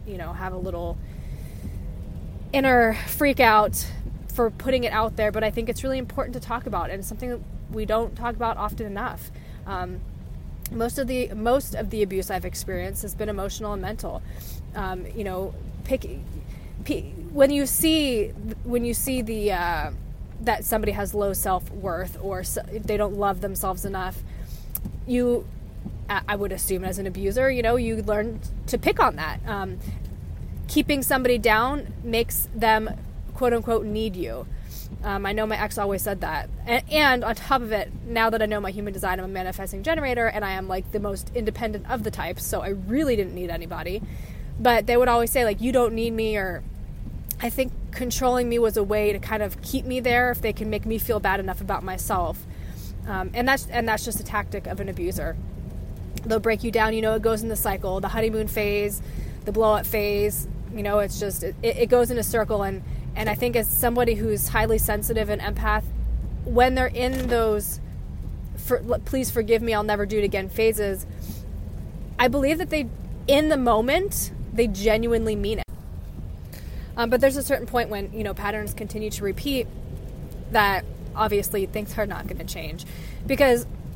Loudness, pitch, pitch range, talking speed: -25 LUFS, 220 Hz, 205-245 Hz, 195 wpm